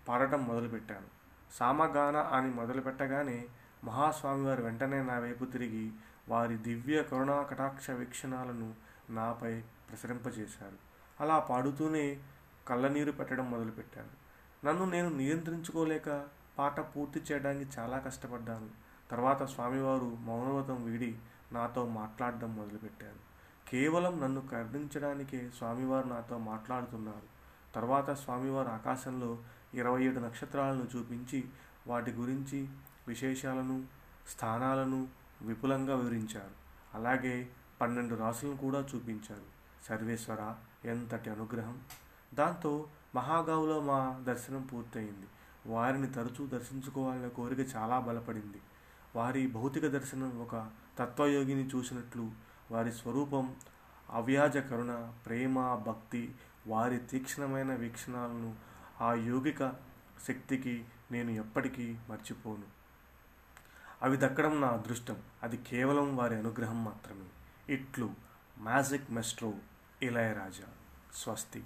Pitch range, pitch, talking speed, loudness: 115-135 Hz, 125 Hz, 90 wpm, -36 LUFS